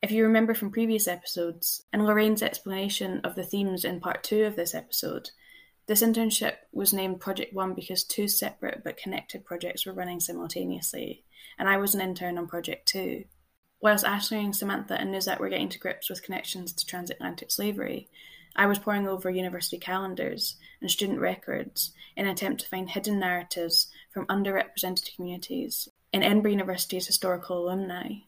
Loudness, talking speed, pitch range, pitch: -28 LUFS, 170 wpm, 180-210 Hz, 190 Hz